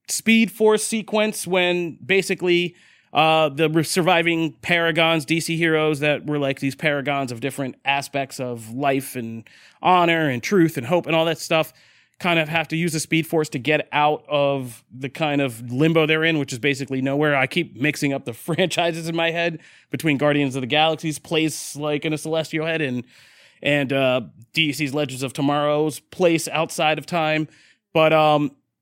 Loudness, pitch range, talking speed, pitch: -21 LUFS, 140-165 Hz, 180 wpm, 155 Hz